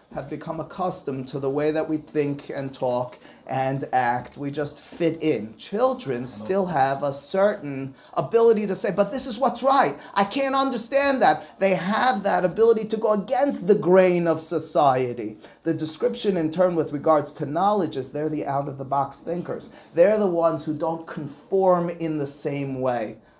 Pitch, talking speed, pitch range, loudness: 160 Hz, 180 wpm, 140-200 Hz, -23 LUFS